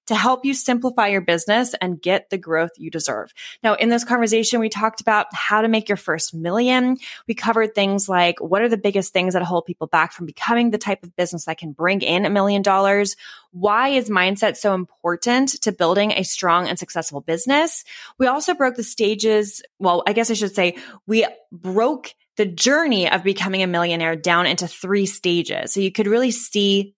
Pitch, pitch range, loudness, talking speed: 200 Hz, 175-230 Hz, -19 LUFS, 200 wpm